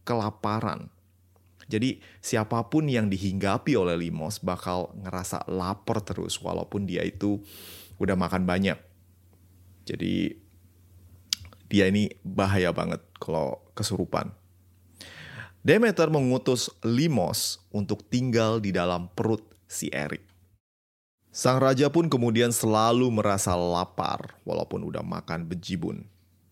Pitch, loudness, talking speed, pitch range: 95 Hz, -27 LUFS, 100 wpm, 90-110 Hz